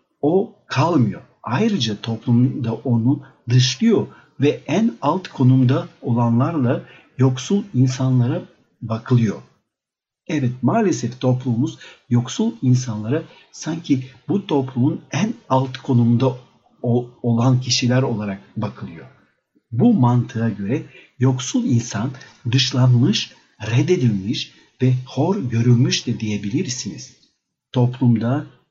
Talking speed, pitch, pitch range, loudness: 90 wpm, 125 Hz, 120-135 Hz, -20 LUFS